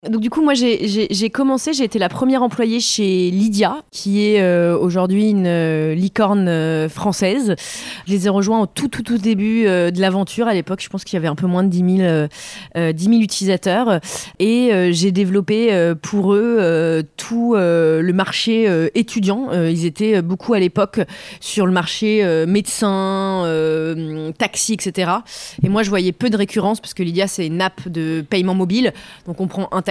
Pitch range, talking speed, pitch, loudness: 175-215 Hz, 205 wpm, 195 Hz, -17 LUFS